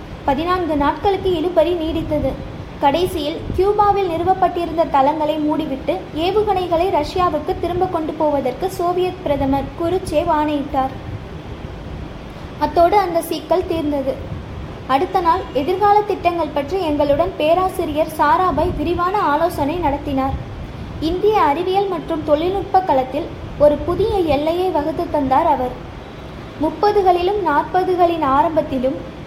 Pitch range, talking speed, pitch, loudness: 300-365 Hz, 95 wpm, 330 Hz, -18 LUFS